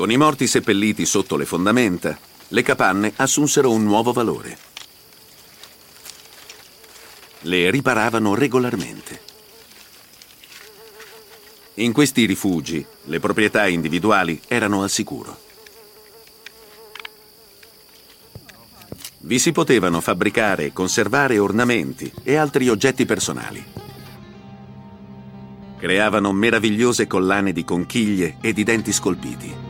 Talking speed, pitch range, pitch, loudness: 90 wpm, 90-130 Hz, 105 Hz, -19 LUFS